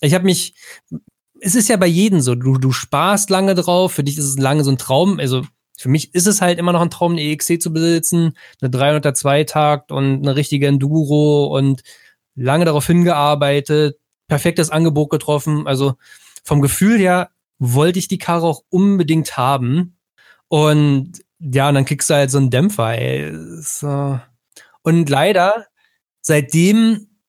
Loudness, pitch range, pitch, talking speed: -16 LUFS, 140-175 Hz, 150 Hz, 165 wpm